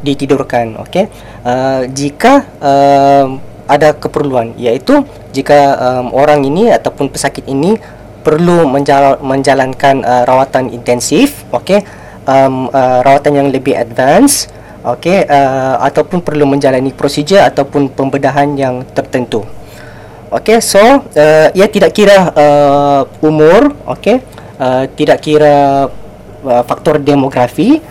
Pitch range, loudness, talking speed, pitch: 125-150 Hz, -9 LUFS, 115 wpm, 140 Hz